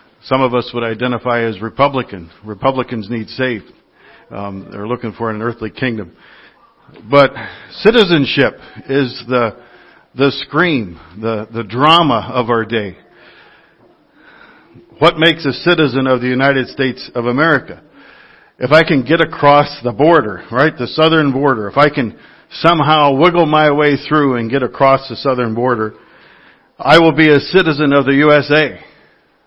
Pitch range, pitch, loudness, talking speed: 115-145 Hz, 130 Hz, -13 LUFS, 145 wpm